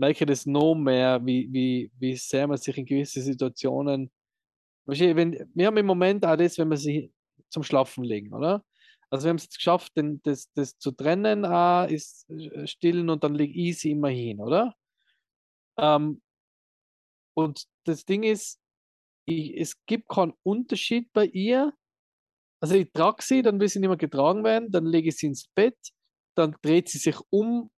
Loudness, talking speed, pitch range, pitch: -25 LUFS, 170 wpm, 140-190 Hz, 160 Hz